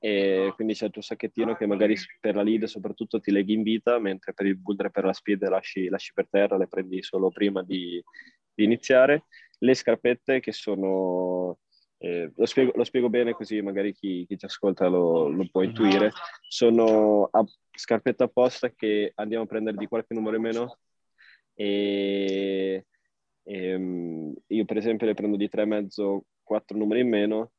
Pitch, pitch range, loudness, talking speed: 105 Hz, 95-115 Hz, -26 LUFS, 180 wpm